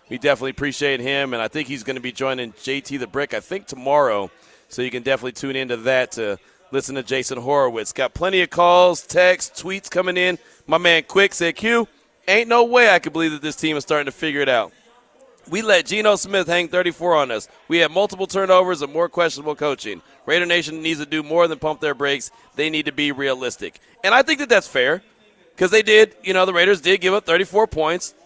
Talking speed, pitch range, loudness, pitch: 225 wpm, 140-185 Hz, -19 LUFS, 160 Hz